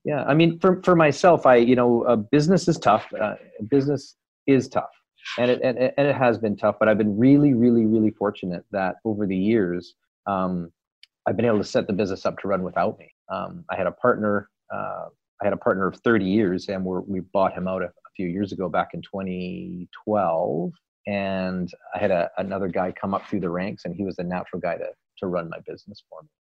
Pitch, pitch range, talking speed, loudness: 105 Hz, 95-125 Hz, 225 wpm, -23 LUFS